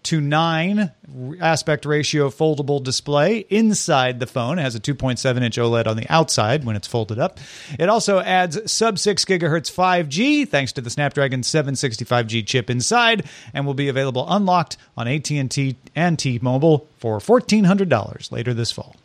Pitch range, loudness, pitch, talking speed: 125-175 Hz, -19 LUFS, 145 Hz, 160 wpm